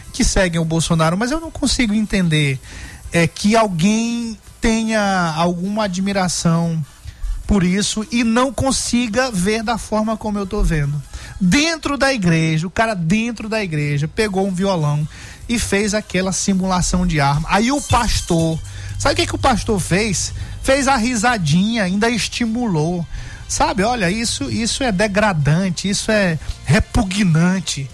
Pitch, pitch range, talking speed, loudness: 195 Hz, 165-225 Hz, 145 wpm, -18 LUFS